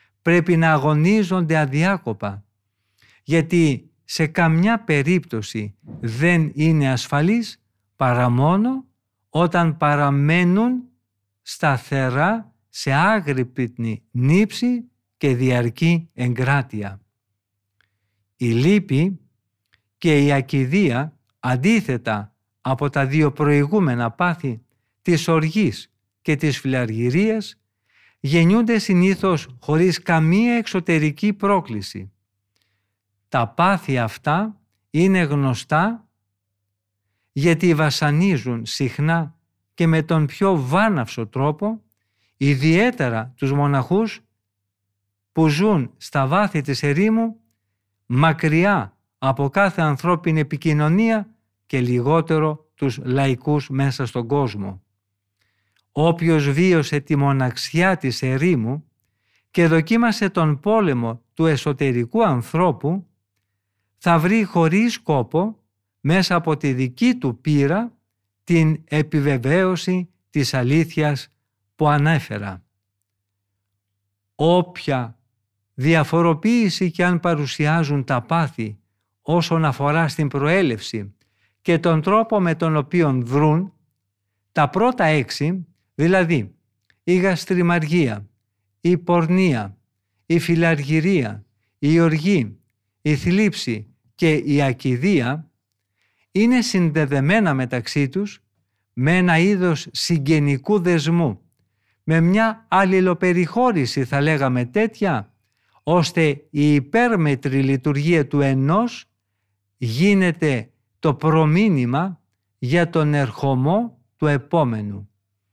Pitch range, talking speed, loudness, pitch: 115-170 Hz, 90 wpm, -19 LUFS, 145 Hz